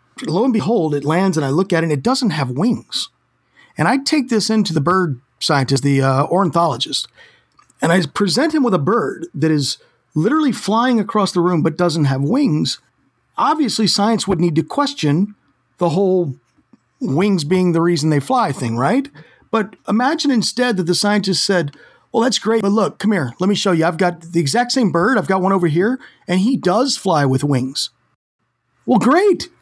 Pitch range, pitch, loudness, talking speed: 160-230 Hz, 190 Hz, -17 LUFS, 195 wpm